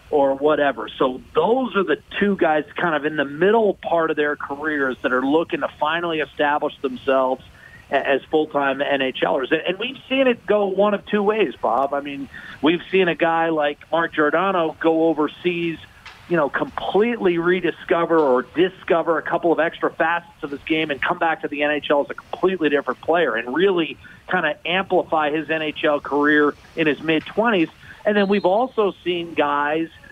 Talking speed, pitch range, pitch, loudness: 180 wpm, 150-180 Hz, 160 Hz, -20 LUFS